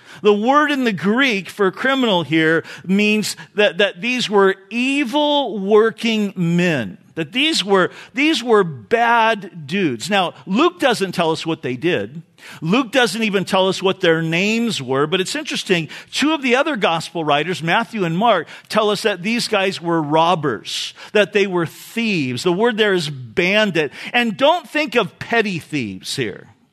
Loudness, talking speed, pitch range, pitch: -18 LUFS, 170 wpm, 170-235 Hz, 200 Hz